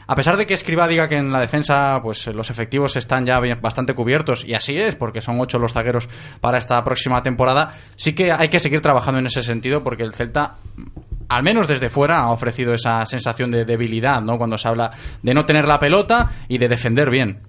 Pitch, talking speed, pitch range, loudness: 125 Hz, 220 wpm, 120-145 Hz, -18 LUFS